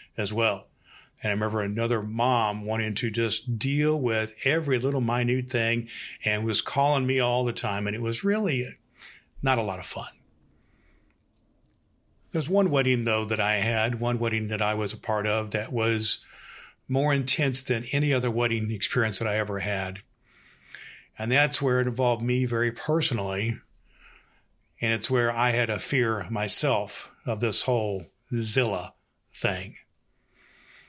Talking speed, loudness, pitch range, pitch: 155 wpm, -26 LUFS, 110-130 Hz, 115 Hz